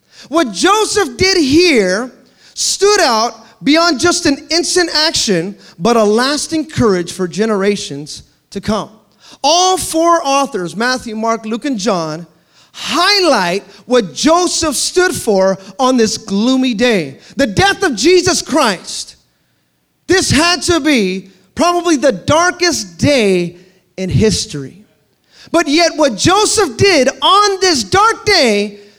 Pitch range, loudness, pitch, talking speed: 205-340 Hz, -12 LUFS, 260 Hz, 125 wpm